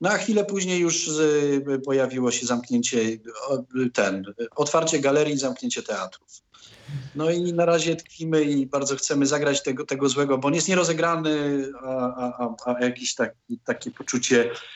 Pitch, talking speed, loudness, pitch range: 140 Hz, 145 wpm, -24 LUFS, 125-160 Hz